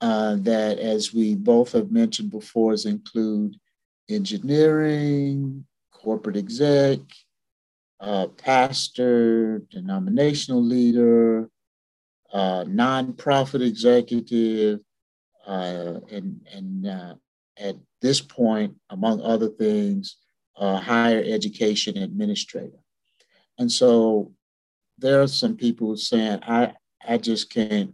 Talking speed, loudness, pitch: 95 wpm, -22 LUFS, 120 Hz